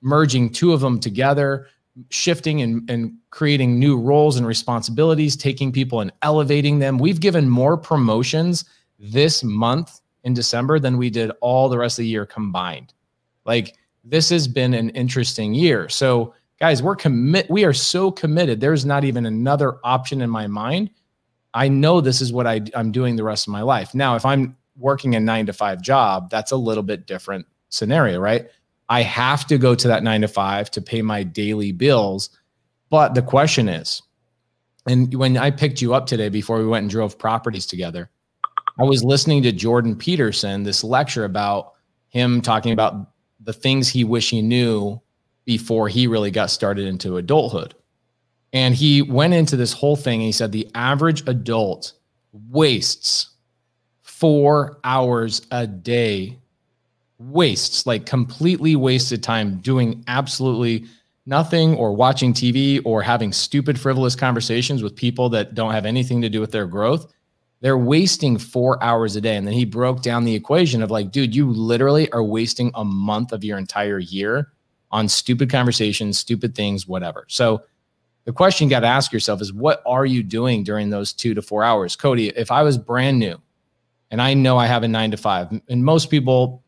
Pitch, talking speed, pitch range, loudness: 120 Hz, 180 wpm, 110-140 Hz, -19 LUFS